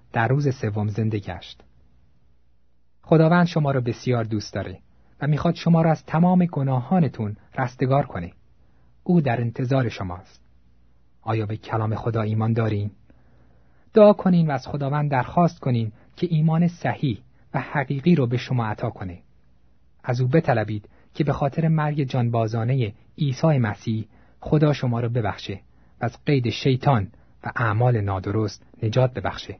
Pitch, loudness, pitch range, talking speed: 115 Hz, -23 LUFS, 100-140 Hz, 140 wpm